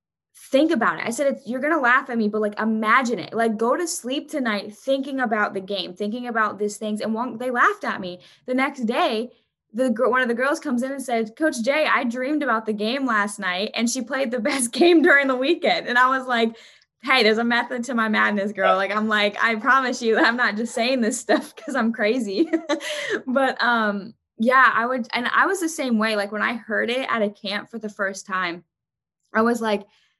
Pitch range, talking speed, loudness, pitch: 215-265 Hz, 230 wpm, -21 LUFS, 235 Hz